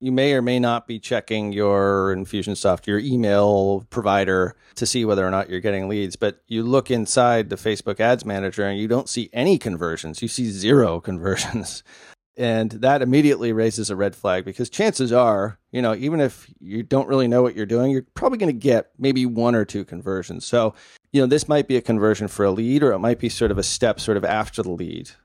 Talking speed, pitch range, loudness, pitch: 220 wpm, 100-125 Hz, -21 LUFS, 110 Hz